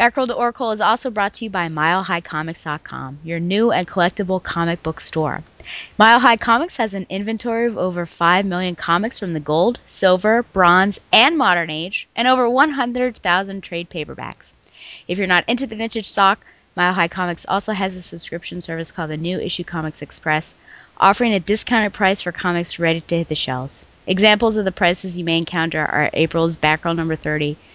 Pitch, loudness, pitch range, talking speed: 180 Hz, -18 LUFS, 165-215 Hz, 185 wpm